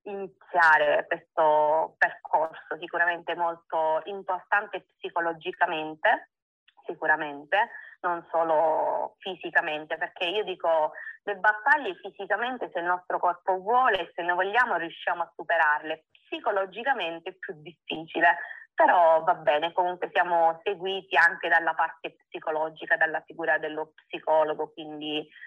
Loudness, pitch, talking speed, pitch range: -26 LUFS, 175 Hz, 115 wpm, 160-195 Hz